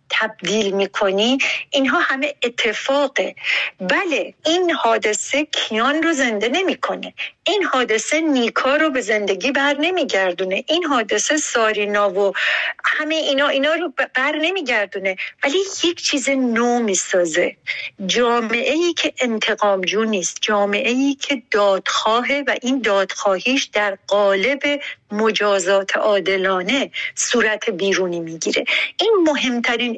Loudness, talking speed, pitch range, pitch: -18 LUFS, 110 wpm, 205-285 Hz, 240 Hz